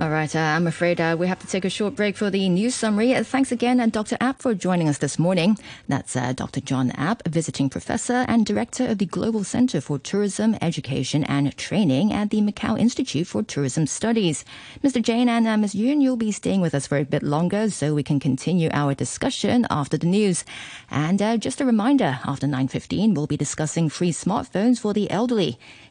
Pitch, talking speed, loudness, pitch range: 190 Hz, 210 wpm, -22 LUFS, 150-225 Hz